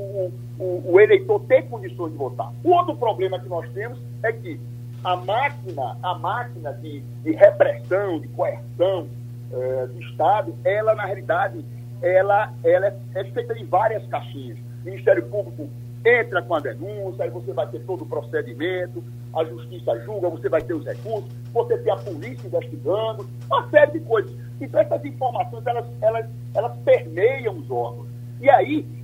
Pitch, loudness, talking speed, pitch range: 125 Hz, -22 LUFS, 165 wpm, 120-180 Hz